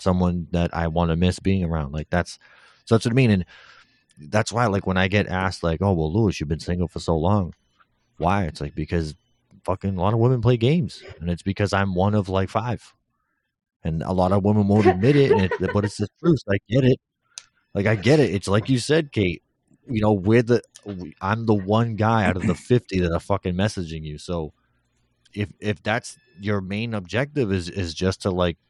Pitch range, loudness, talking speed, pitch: 90-110 Hz, -22 LUFS, 225 wpm, 100 Hz